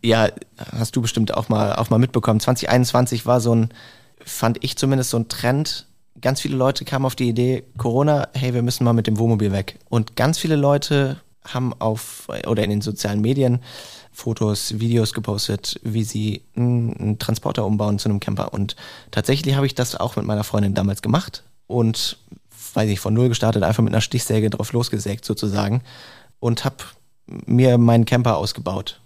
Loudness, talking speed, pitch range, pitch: -20 LUFS, 180 wpm, 110-125 Hz, 115 Hz